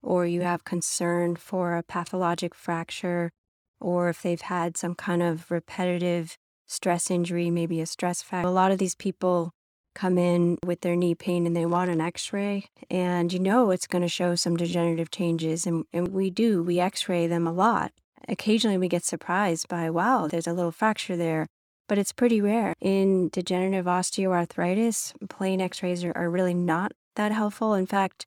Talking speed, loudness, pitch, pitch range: 185 wpm, -26 LUFS, 175 Hz, 170-190 Hz